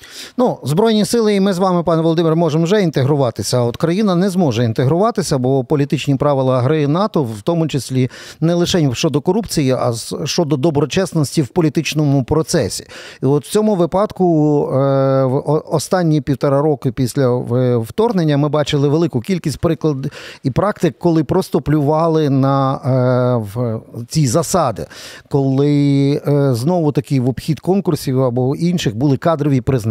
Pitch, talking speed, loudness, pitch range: 150 Hz, 140 wpm, -16 LUFS, 135-170 Hz